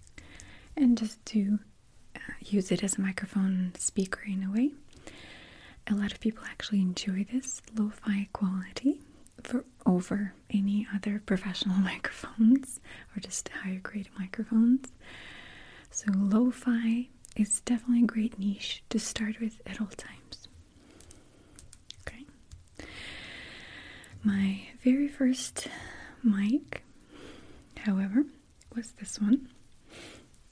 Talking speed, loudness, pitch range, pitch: 110 wpm, -30 LUFS, 195-240 Hz, 210 Hz